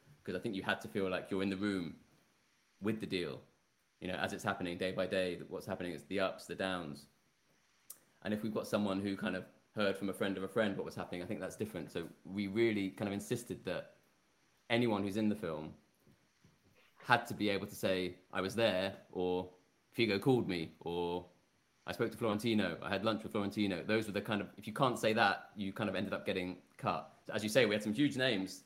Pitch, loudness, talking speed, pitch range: 100 Hz, -37 LUFS, 235 wpm, 95-110 Hz